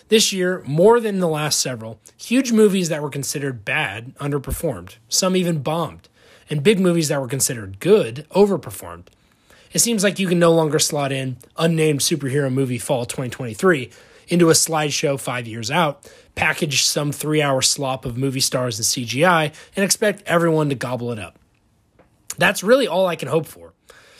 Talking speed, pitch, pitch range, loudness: 170 wpm, 150 Hz, 130-175 Hz, -19 LUFS